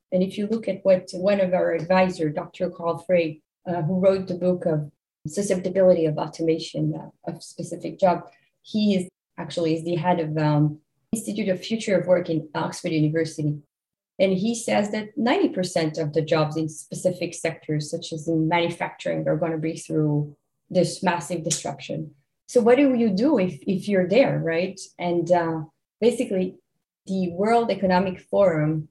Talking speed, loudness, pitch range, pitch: 170 wpm, -24 LUFS, 160-185 Hz, 175 Hz